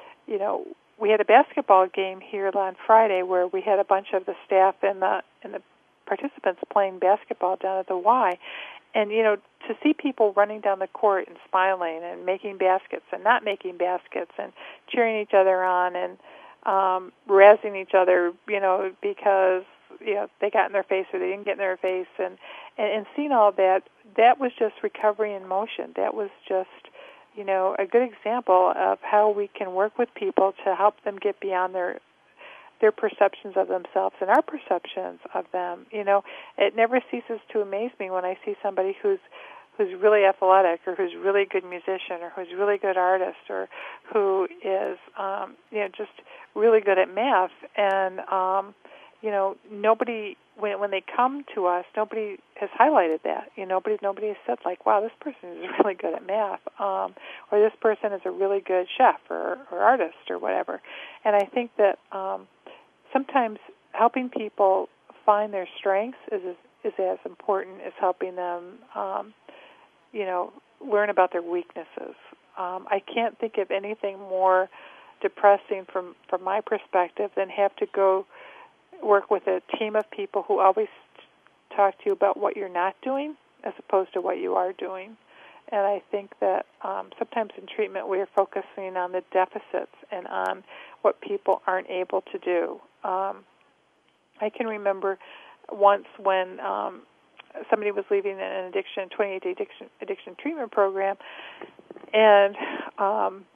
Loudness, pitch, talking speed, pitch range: -25 LUFS, 200 Hz, 175 wpm, 190-225 Hz